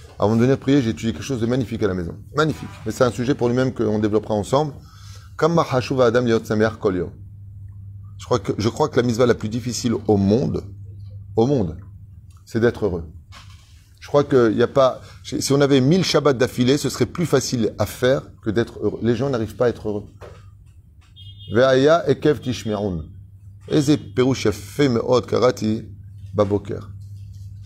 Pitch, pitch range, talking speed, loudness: 110 Hz, 100-125 Hz, 165 wpm, -20 LUFS